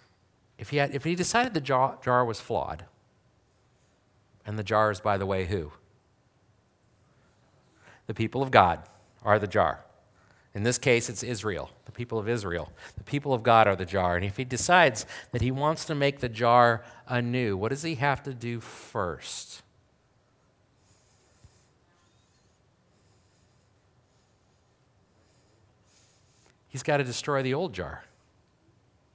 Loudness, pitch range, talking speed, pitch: -27 LUFS, 100-130 Hz, 140 wpm, 115 Hz